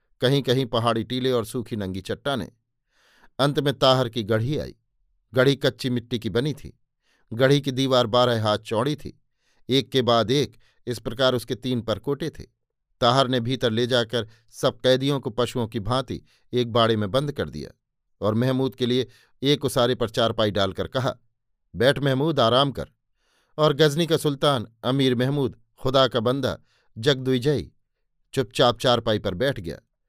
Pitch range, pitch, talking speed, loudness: 115-135 Hz, 125 Hz, 165 wpm, -23 LUFS